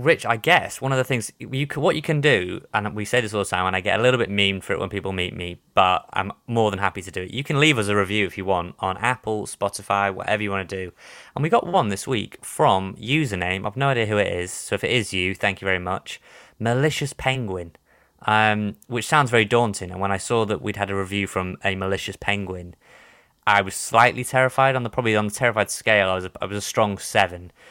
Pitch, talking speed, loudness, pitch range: 105 Hz, 260 wpm, -22 LUFS, 95-120 Hz